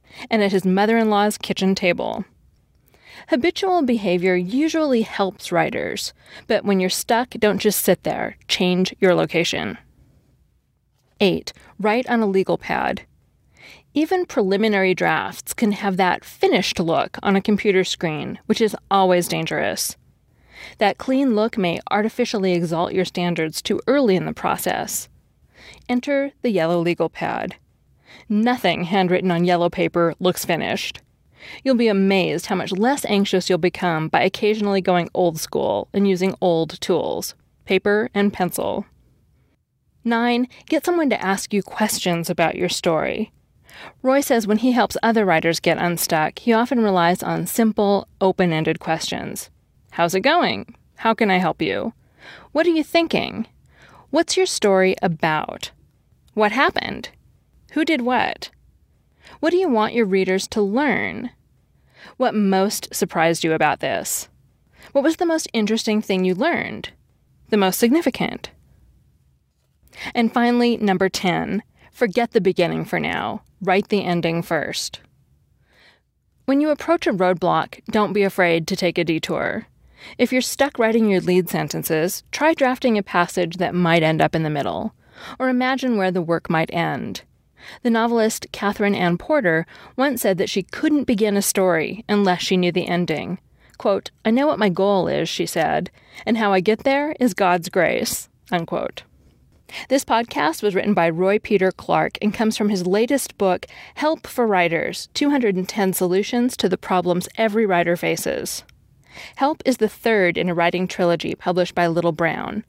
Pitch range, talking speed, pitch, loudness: 180-235 Hz, 155 wpm, 200 Hz, -20 LUFS